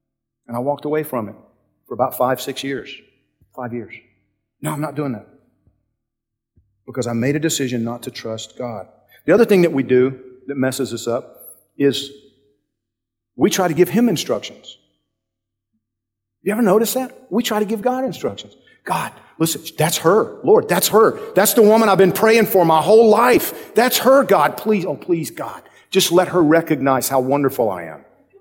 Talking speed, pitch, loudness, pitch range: 180 wpm, 140 Hz, -17 LUFS, 120-190 Hz